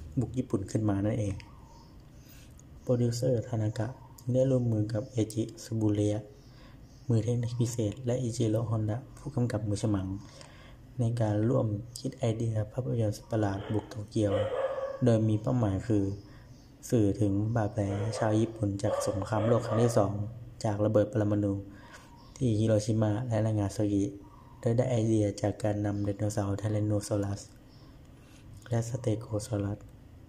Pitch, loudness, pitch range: 110 Hz, -30 LUFS, 105-125 Hz